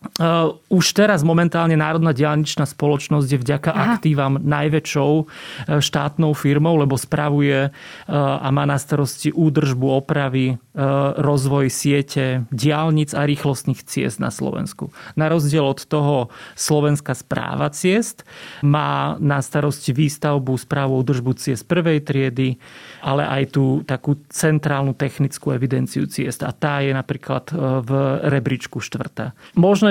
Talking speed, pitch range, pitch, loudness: 120 wpm, 135-155 Hz, 145 Hz, -19 LUFS